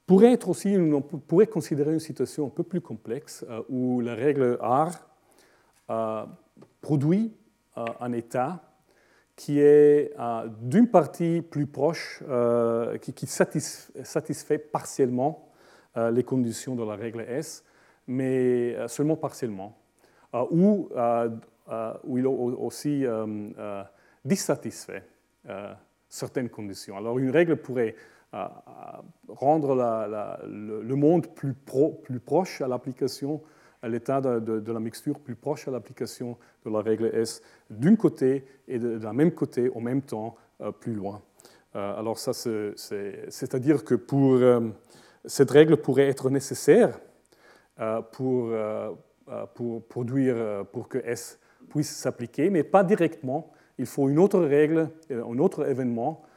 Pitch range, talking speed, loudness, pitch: 115-150 Hz, 140 wpm, -26 LUFS, 130 Hz